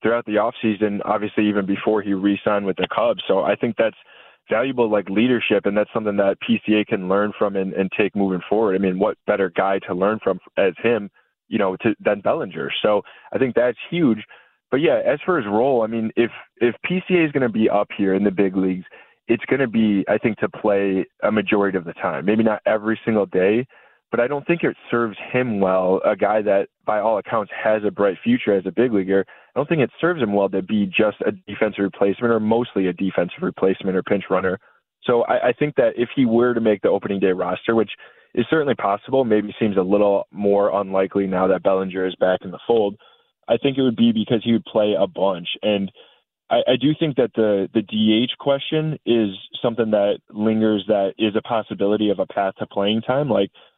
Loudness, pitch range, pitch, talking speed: -20 LUFS, 100-115 Hz, 105 Hz, 225 wpm